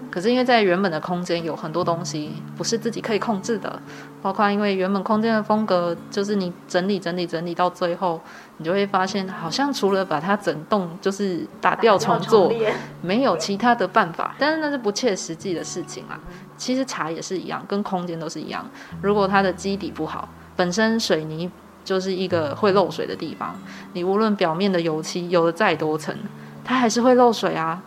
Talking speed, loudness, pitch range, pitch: 305 characters per minute, -22 LUFS, 175-215 Hz, 190 Hz